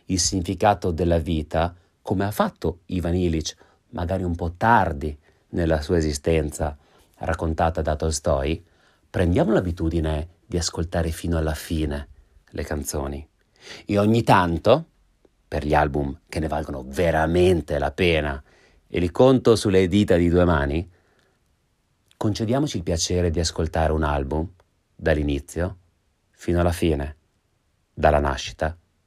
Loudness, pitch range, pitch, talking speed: -23 LUFS, 75-90 Hz, 85 Hz, 125 wpm